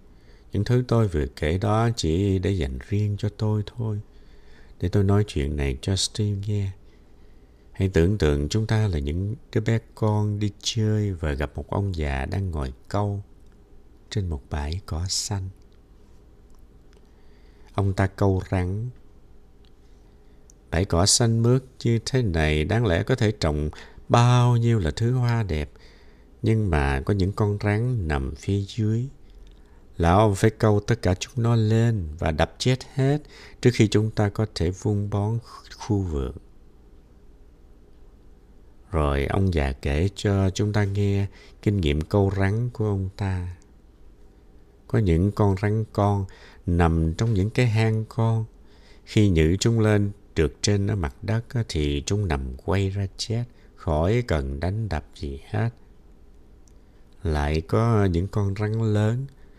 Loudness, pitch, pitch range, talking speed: -24 LUFS, 100 Hz, 80-110 Hz, 155 wpm